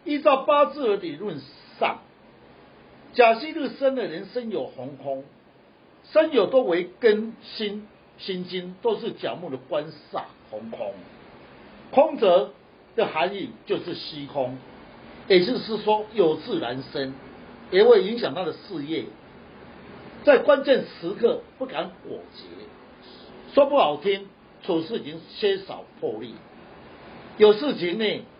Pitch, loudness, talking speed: 220 Hz, -24 LUFS, 180 characters per minute